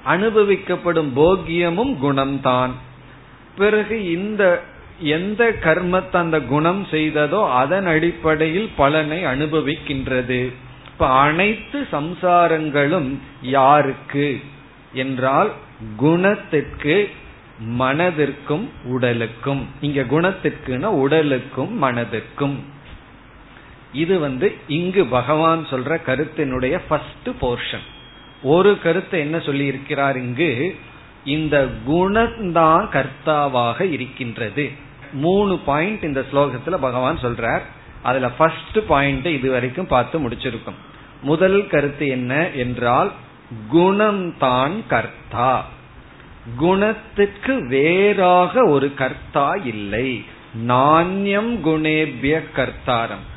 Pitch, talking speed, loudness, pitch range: 145 Hz, 70 wpm, -19 LUFS, 130-170 Hz